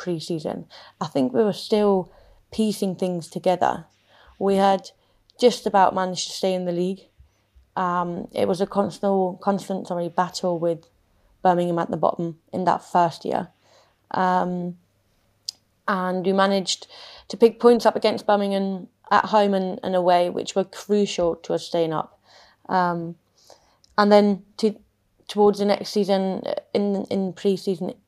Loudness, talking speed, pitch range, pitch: -23 LUFS, 150 wpm, 175-200 Hz, 185 Hz